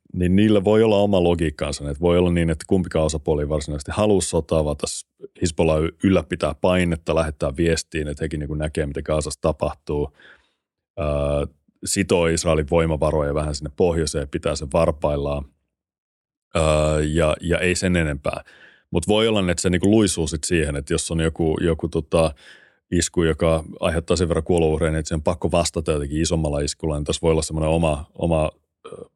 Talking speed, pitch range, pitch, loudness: 175 wpm, 75-85 Hz, 80 Hz, -21 LUFS